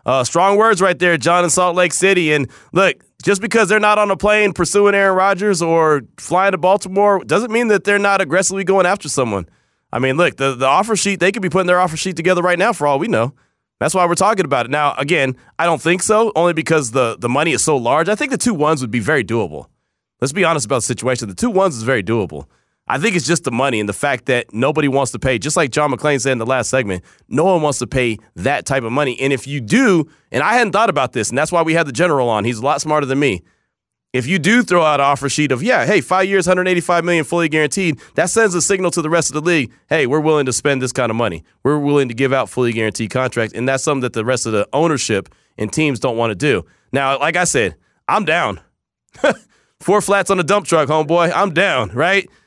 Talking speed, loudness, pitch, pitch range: 260 wpm, -16 LUFS, 155 Hz, 130-185 Hz